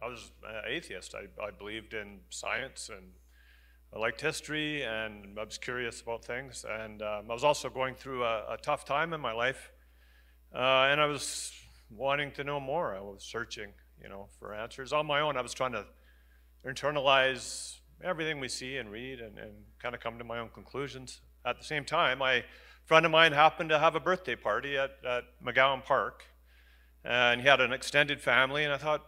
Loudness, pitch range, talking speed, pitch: -30 LUFS, 100-140 Hz, 200 wpm, 120 Hz